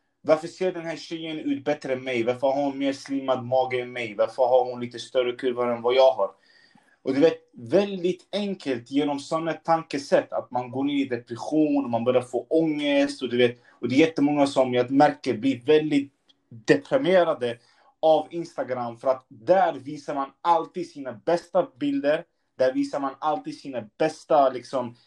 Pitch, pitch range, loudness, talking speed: 140 Hz, 125-160 Hz, -25 LUFS, 185 wpm